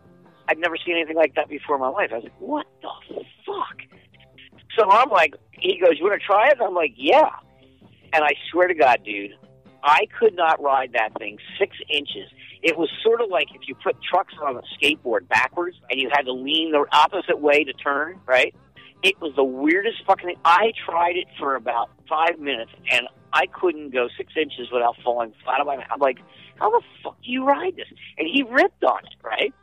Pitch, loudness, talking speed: 165 Hz, -21 LUFS, 220 wpm